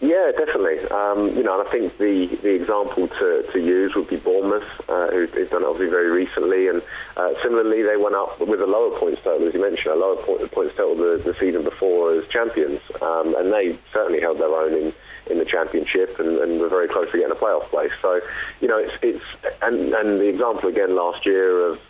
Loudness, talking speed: -21 LUFS, 225 wpm